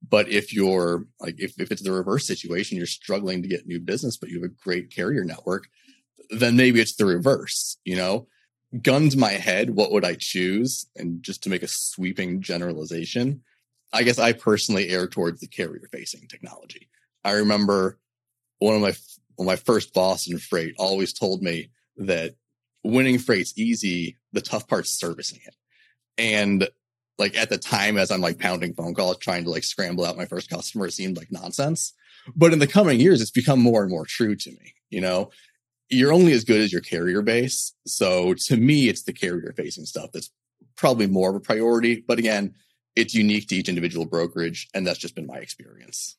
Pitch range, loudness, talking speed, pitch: 90-125 Hz, -23 LUFS, 195 wpm, 105 Hz